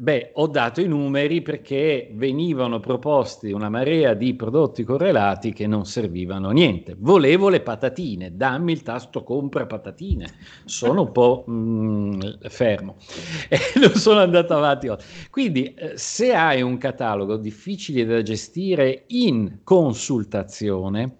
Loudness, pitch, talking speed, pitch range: -21 LUFS, 130 Hz, 130 wpm, 110-155 Hz